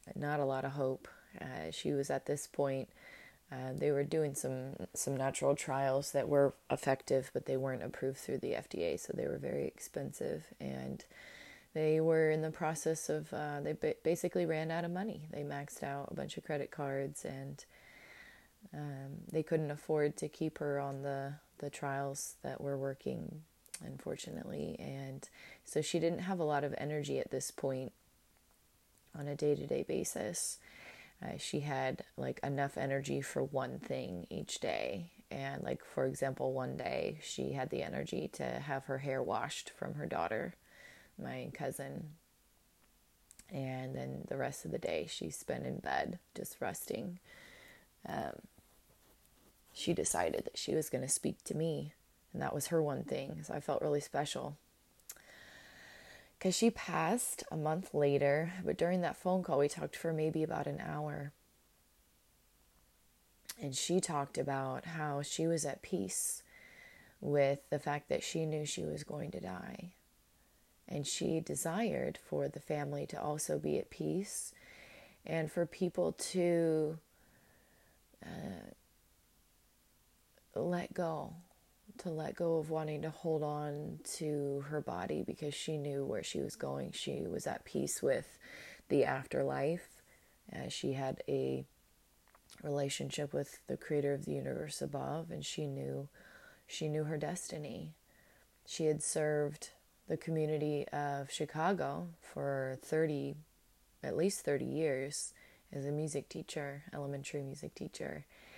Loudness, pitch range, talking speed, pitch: -38 LUFS, 135-160 Hz, 150 wpm, 145 Hz